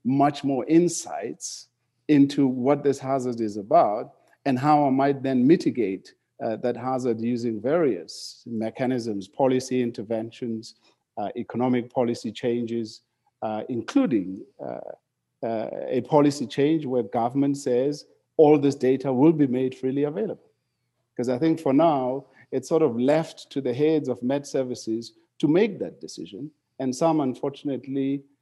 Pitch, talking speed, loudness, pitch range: 130 Hz, 140 wpm, -24 LUFS, 120-140 Hz